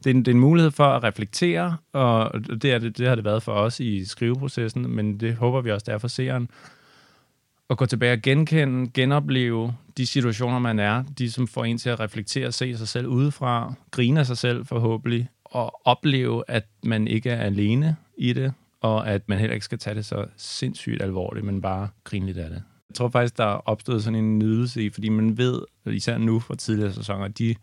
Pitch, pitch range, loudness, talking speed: 120 Hz, 110-130 Hz, -24 LUFS, 225 wpm